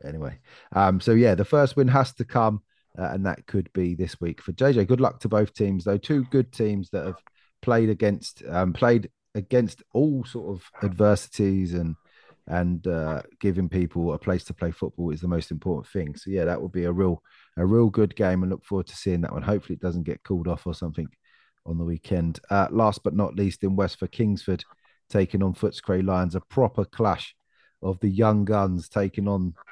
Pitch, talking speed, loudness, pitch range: 95 Hz, 210 wpm, -25 LUFS, 90-105 Hz